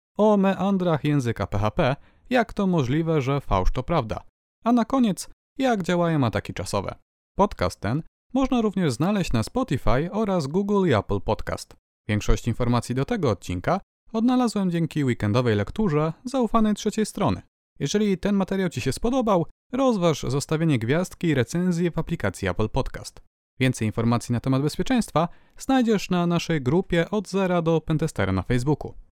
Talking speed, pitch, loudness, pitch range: 150 wpm, 160 Hz, -24 LUFS, 120-195 Hz